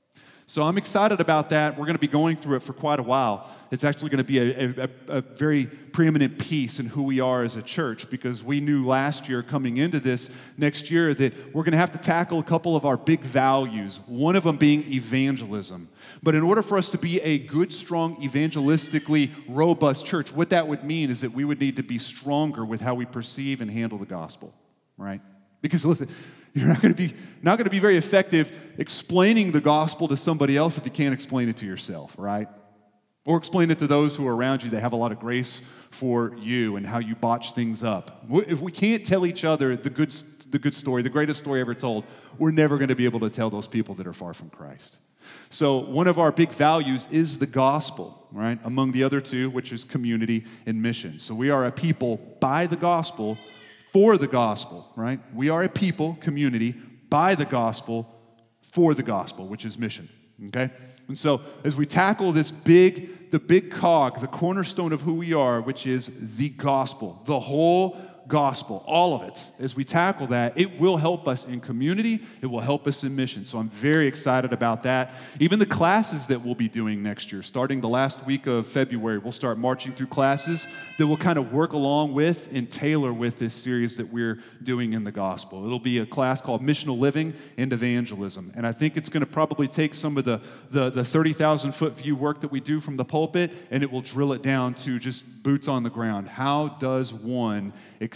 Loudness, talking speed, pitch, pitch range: -24 LUFS, 220 wpm, 135 Hz, 120-155 Hz